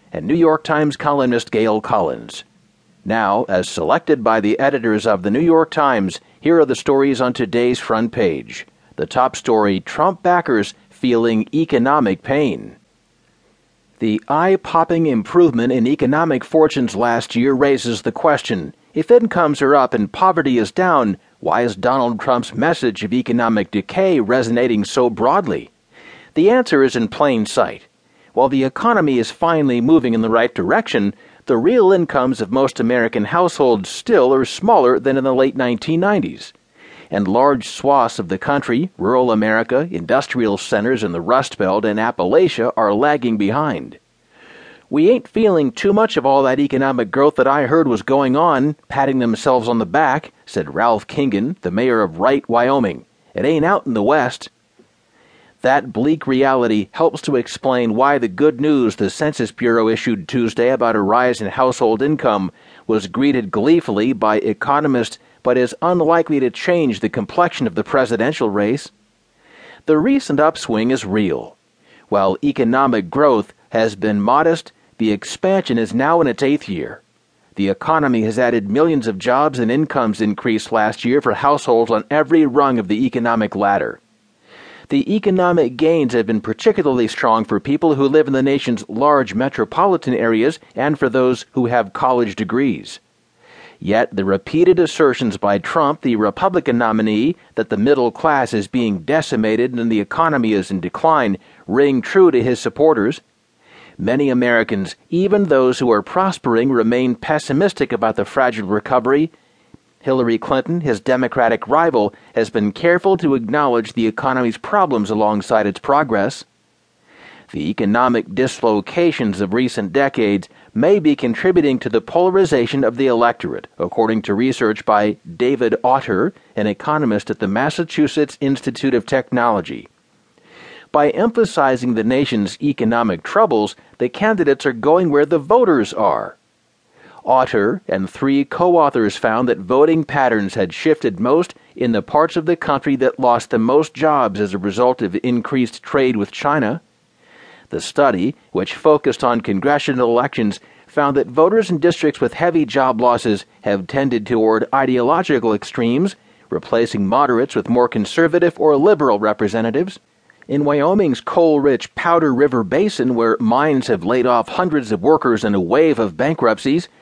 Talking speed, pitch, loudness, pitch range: 155 wpm, 130 Hz, -16 LUFS, 115-155 Hz